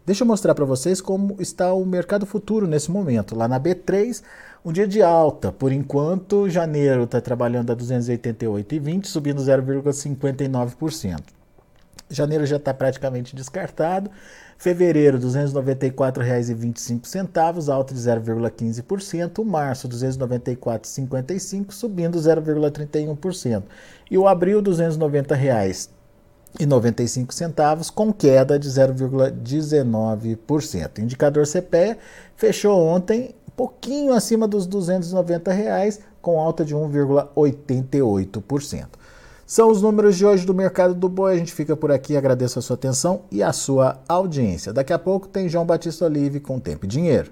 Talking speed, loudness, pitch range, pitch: 130 wpm, -21 LUFS, 130-185 Hz, 150 Hz